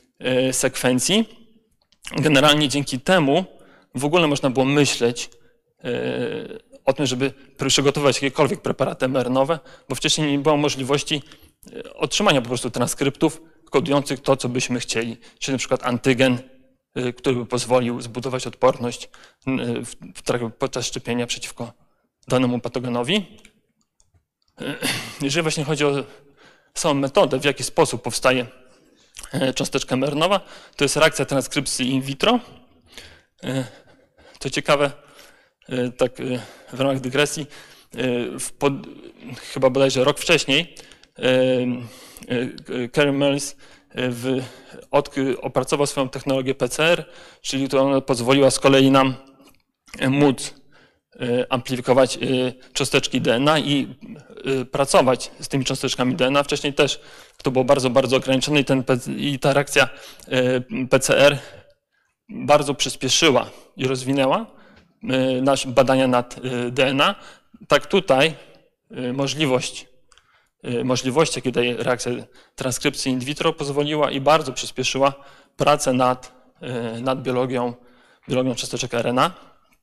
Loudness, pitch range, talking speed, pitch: -21 LUFS, 125-145 Hz, 105 wpm, 135 Hz